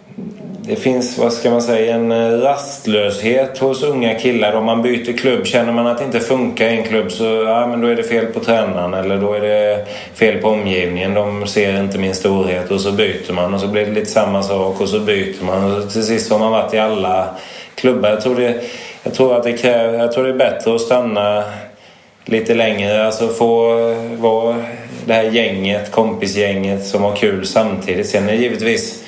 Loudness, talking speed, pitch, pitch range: -16 LUFS, 210 wpm, 115 Hz, 105-120 Hz